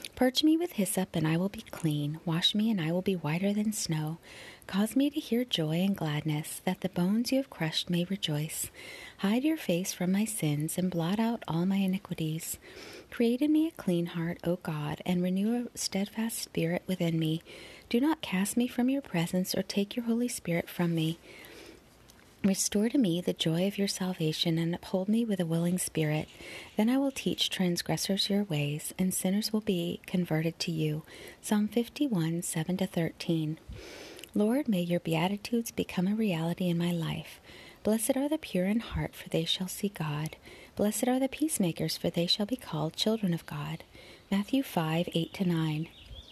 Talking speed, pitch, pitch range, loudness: 190 wpm, 185 Hz, 165-220 Hz, -31 LUFS